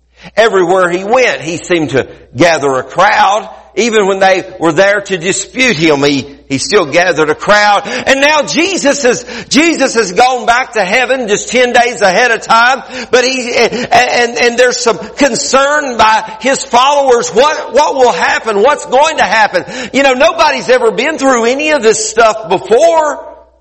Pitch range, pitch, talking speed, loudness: 195-265 Hz, 235 Hz, 175 wpm, -9 LUFS